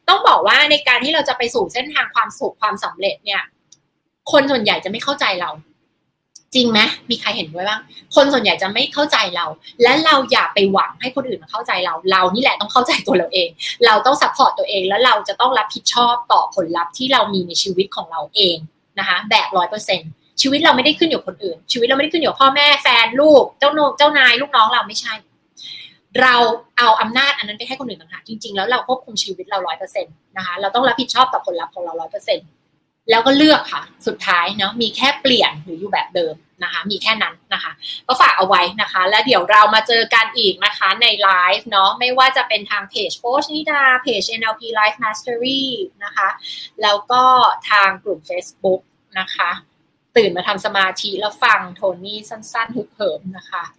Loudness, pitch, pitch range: -15 LUFS, 220 Hz, 195-260 Hz